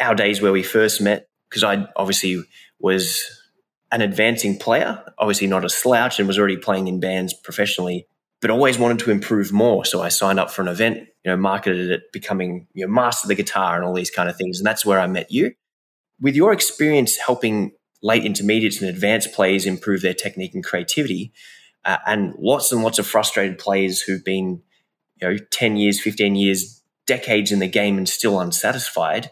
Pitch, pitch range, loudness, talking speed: 100 Hz, 95-110 Hz, -19 LUFS, 200 wpm